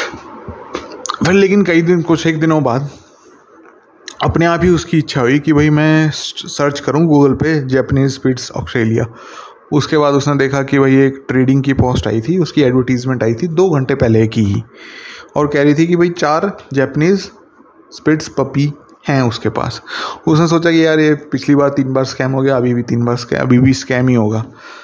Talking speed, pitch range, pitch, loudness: 190 wpm, 130-160 Hz, 140 Hz, -13 LUFS